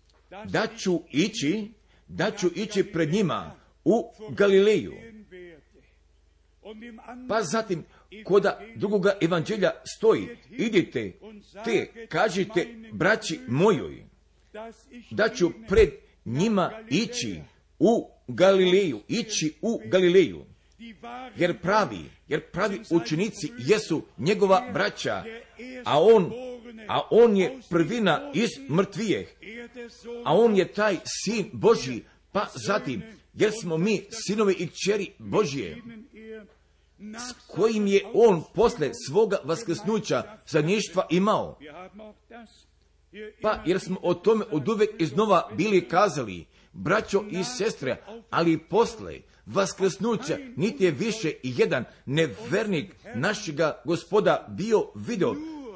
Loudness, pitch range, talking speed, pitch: -25 LUFS, 175-225 Hz, 105 wpm, 205 Hz